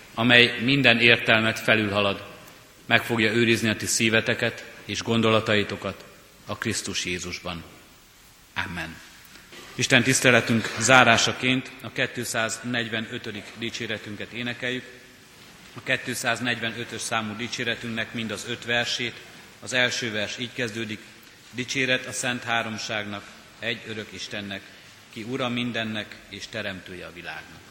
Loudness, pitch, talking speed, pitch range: -23 LUFS, 115 Hz, 110 wpm, 105-120 Hz